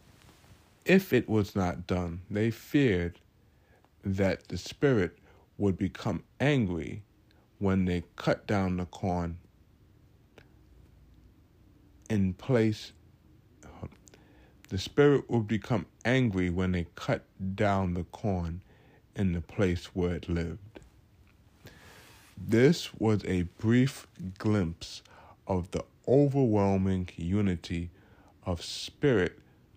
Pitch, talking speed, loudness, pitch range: 100 Hz, 100 wpm, -30 LUFS, 90-110 Hz